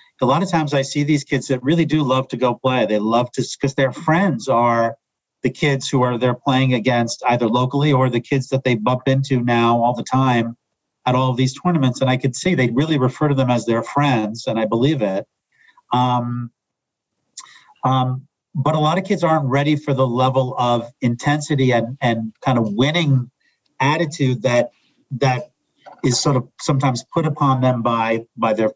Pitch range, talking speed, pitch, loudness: 120-145 Hz, 200 wpm, 130 Hz, -19 LUFS